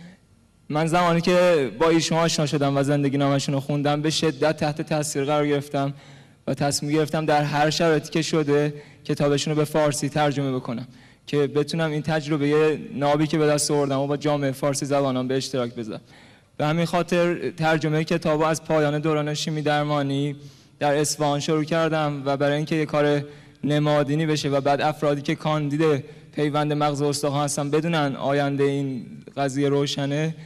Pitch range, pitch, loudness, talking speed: 140-155 Hz, 150 Hz, -23 LUFS, 165 wpm